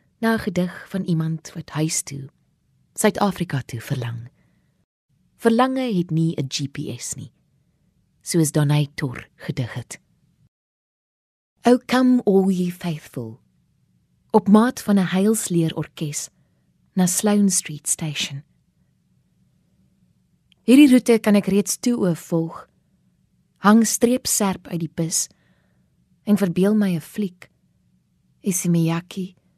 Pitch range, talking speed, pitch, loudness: 150-205 Hz, 105 wpm, 175 Hz, -20 LUFS